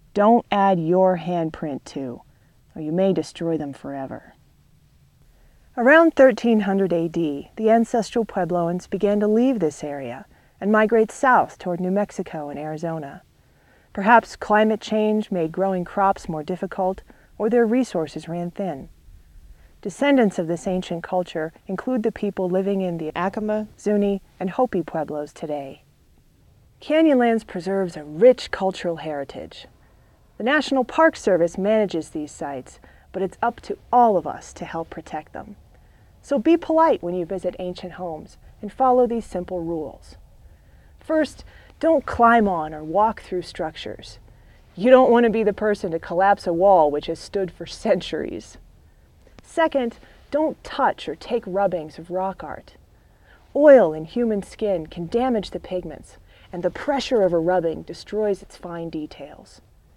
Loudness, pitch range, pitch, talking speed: -21 LUFS, 165-220 Hz, 190 Hz, 150 wpm